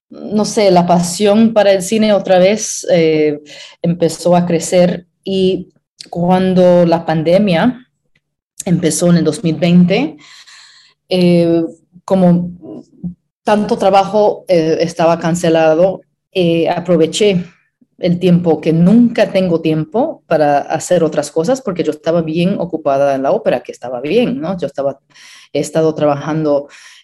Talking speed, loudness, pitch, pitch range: 125 wpm, -13 LUFS, 175 Hz, 160-190 Hz